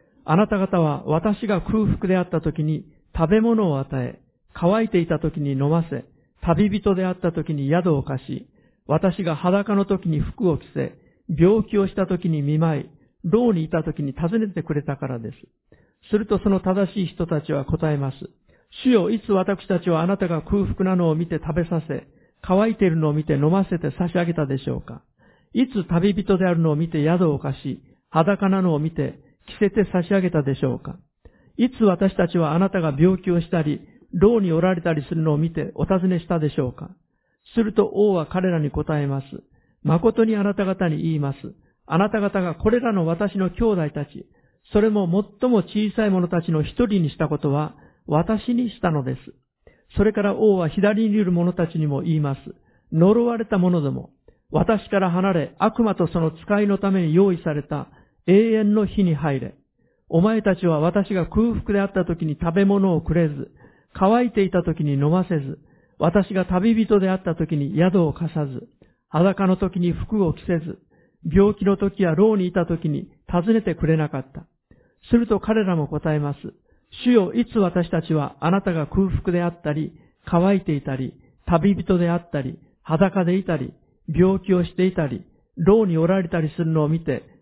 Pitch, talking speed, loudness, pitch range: 175 Hz, 330 characters per minute, -21 LUFS, 155-200 Hz